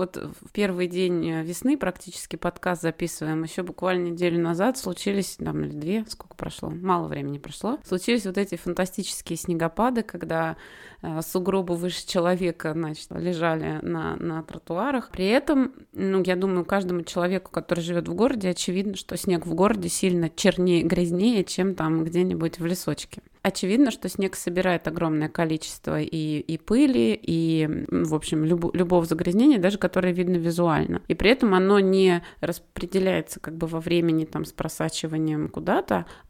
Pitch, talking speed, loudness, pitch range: 175 Hz, 150 wpm, -25 LUFS, 165-190 Hz